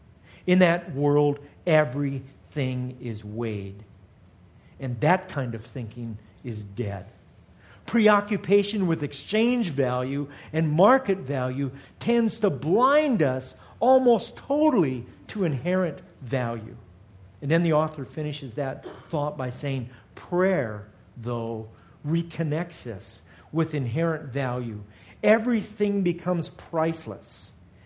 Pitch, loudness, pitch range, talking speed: 140 Hz, -25 LUFS, 115-170 Hz, 105 wpm